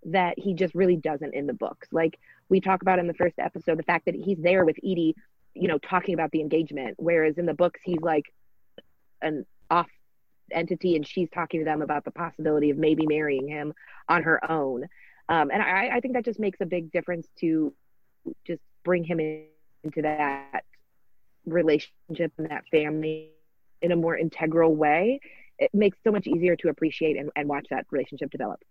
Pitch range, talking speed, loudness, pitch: 155-180 Hz, 195 wpm, -26 LUFS, 165 Hz